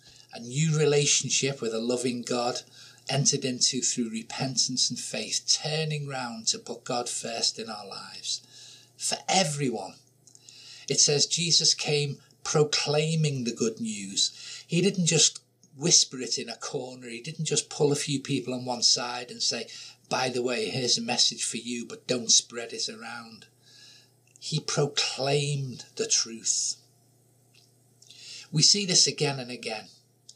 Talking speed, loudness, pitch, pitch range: 150 wpm, -25 LUFS, 130 Hz, 125-145 Hz